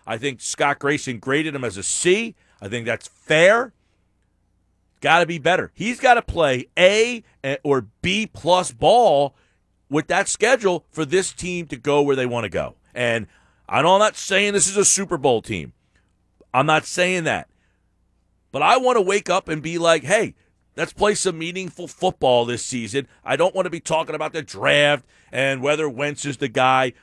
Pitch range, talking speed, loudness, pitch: 120-180 Hz, 190 wpm, -20 LUFS, 145 Hz